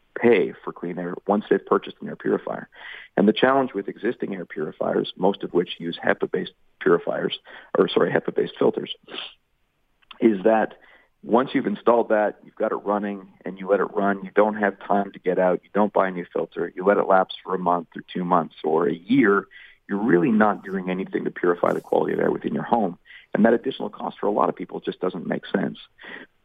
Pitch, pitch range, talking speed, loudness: 100 Hz, 90-105 Hz, 215 wpm, -23 LUFS